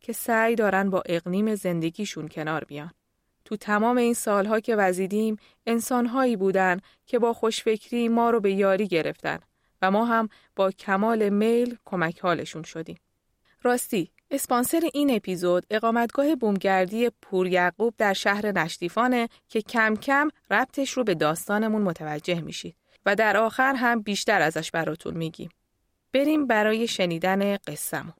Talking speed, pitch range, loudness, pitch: 135 wpm, 185-235 Hz, -25 LUFS, 210 Hz